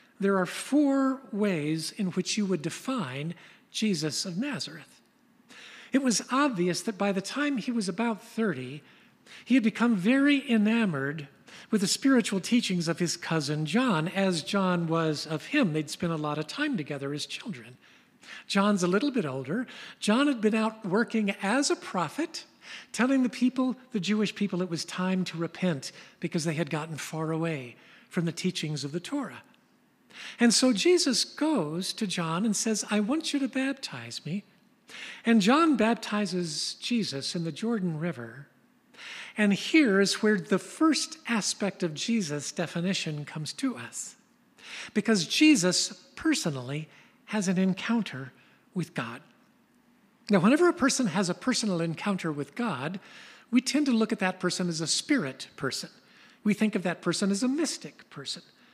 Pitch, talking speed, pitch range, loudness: 205 Hz, 160 wpm, 170-240 Hz, -28 LUFS